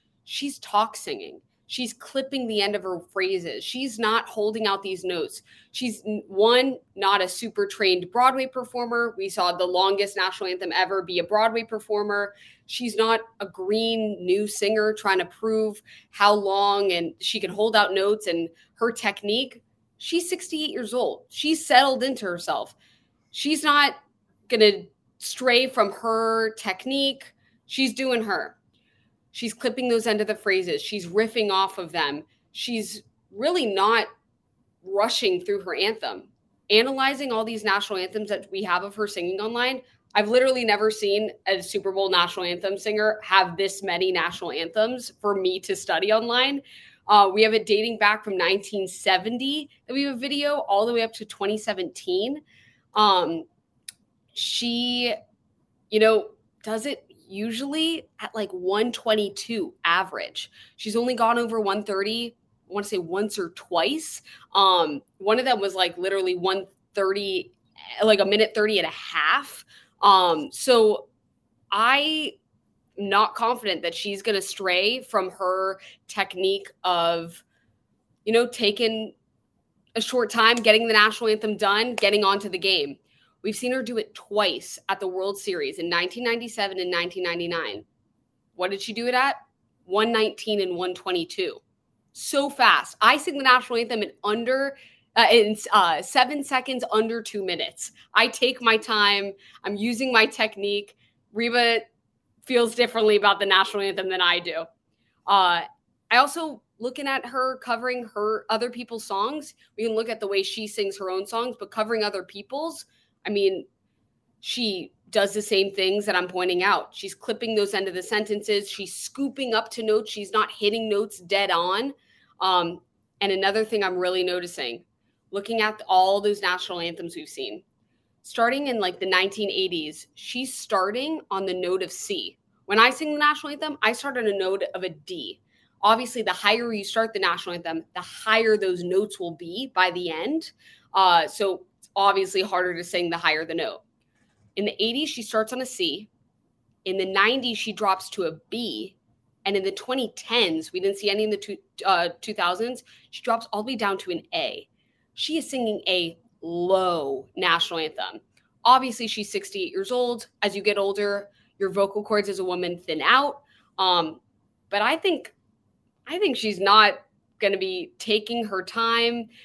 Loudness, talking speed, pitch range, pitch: -24 LUFS, 165 wpm, 195-240 Hz, 210 Hz